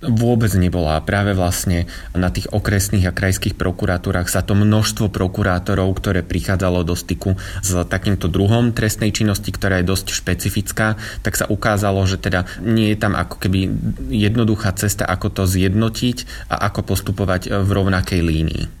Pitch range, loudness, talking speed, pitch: 90-105 Hz, -18 LUFS, 155 wpm, 95 Hz